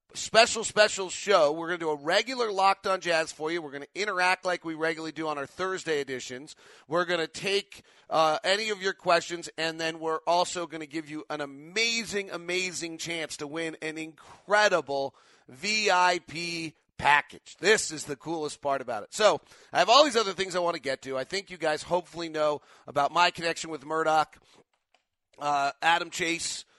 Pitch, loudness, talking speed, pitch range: 165 Hz, -27 LUFS, 195 wpm, 155-185 Hz